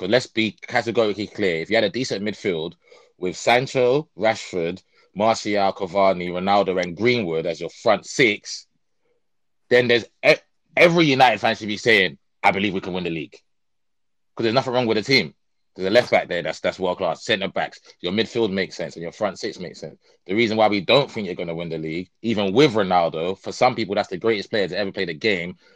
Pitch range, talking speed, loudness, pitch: 95-120 Hz, 215 wpm, -21 LUFS, 110 Hz